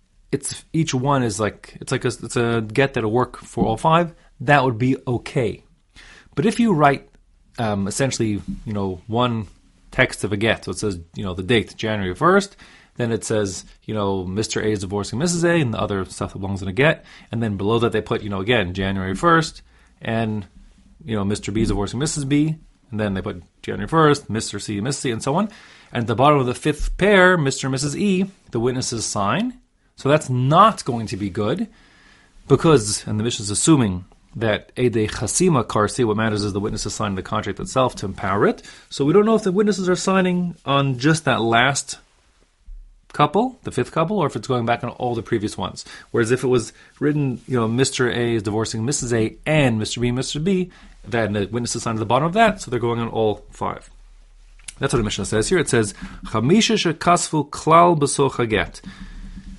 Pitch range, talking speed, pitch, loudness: 105-150 Hz, 215 wpm, 120 Hz, -20 LUFS